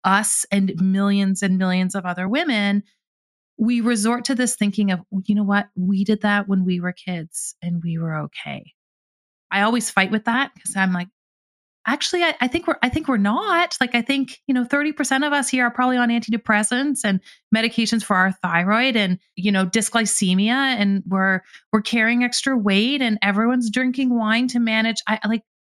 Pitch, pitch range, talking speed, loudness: 220 Hz, 195-245 Hz, 190 wpm, -20 LUFS